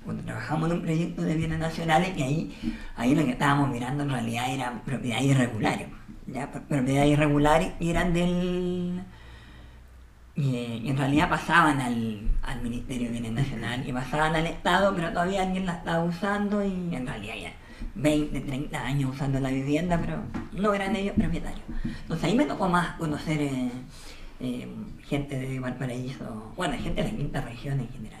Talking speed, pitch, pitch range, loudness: 170 wpm, 145 Hz, 125-170 Hz, -27 LUFS